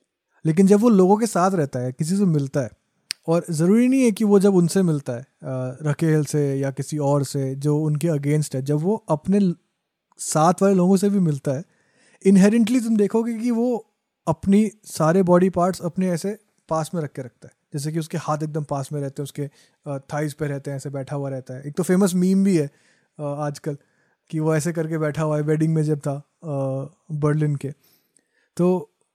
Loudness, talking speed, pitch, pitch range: -21 LUFS, 205 wpm, 160 Hz, 145-190 Hz